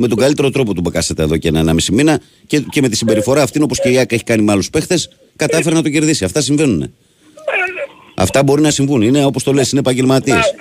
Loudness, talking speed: -14 LUFS, 245 wpm